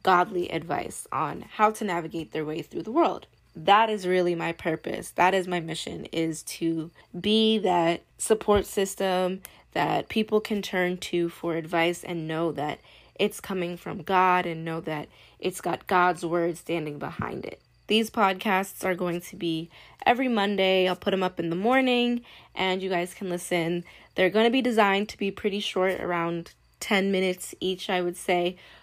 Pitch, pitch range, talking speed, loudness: 185 Hz, 170-200 Hz, 180 wpm, -26 LUFS